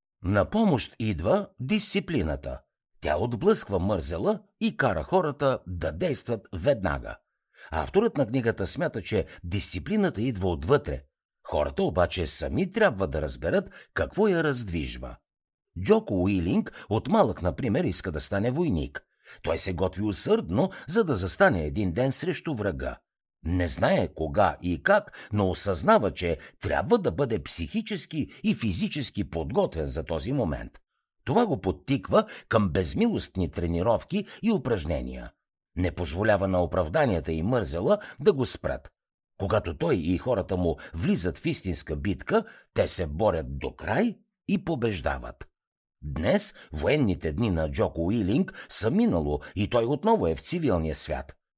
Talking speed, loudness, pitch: 135 wpm, -26 LUFS, 100 Hz